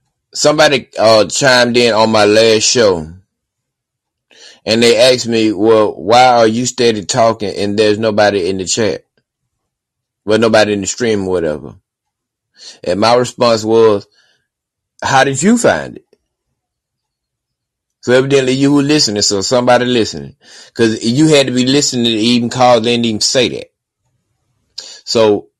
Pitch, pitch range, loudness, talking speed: 115 Hz, 110-125 Hz, -11 LUFS, 150 wpm